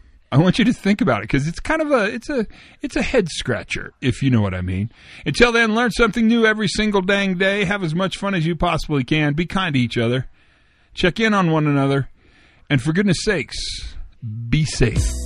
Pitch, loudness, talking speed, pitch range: 170 Hz, -19 LUFS, 225 wpm, 130-210 Hz